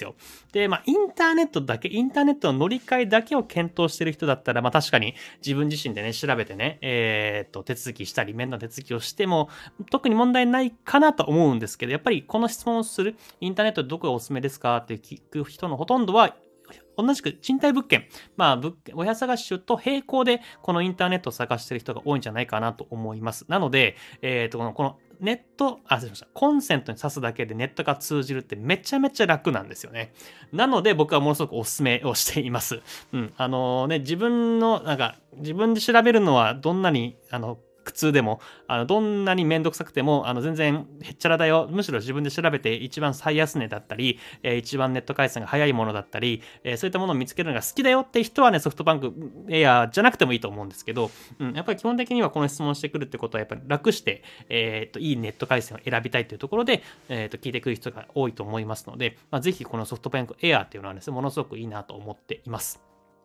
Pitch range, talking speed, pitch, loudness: 120-190 Hz, 470 characters per minute, 145 Hz, -24 LUFS